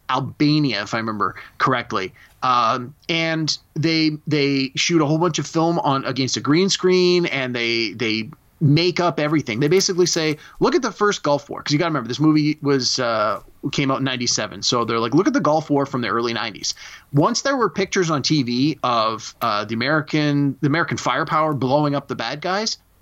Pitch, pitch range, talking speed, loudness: 150 Hz, 130-165 Hz, 205 wpm, -20 LUFS